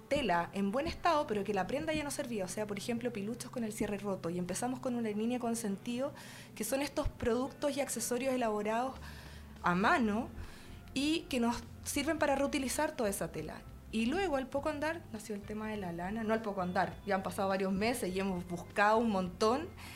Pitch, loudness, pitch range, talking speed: 225 Hz, -35 LUFS, 200-270 Hz, 215 wpm